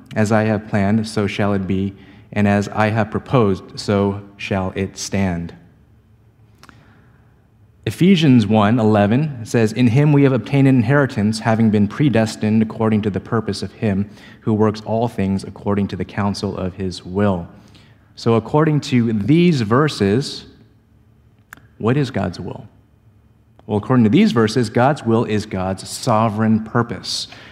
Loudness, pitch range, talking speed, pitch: -18 LUFS, 100-115 Hz, 150 wpm, 110 Hz